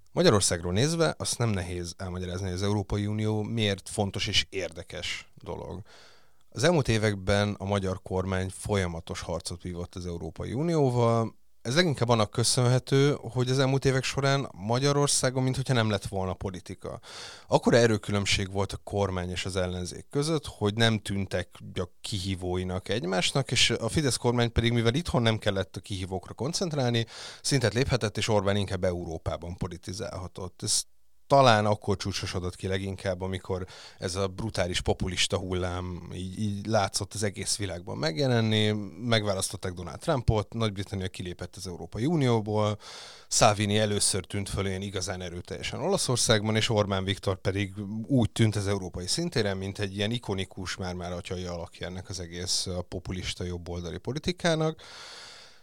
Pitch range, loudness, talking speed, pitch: 95-115 Hz, -28 LUFS, 140 wpm, 100 Hz